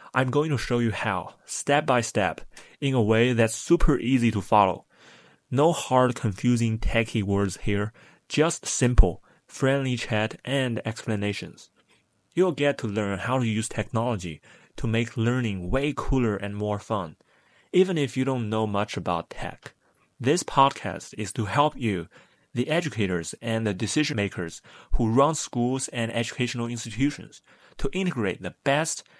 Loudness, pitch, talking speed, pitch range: -26 LUFS, 120 Hz, 155 wpm, 110-135 Hz